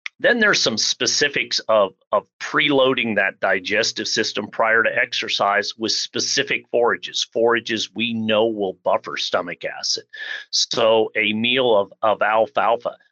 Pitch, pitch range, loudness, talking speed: 115 Hz, 110-135 Hz, -19 LUFS, 135 wpm